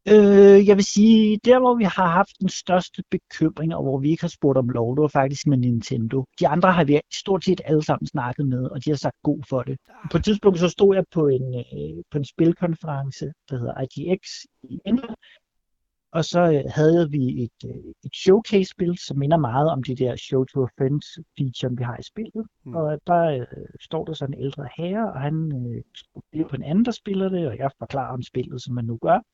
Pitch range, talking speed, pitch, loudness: 135-185 Hz, 210 wpm, 155 Hz, -21 LUFS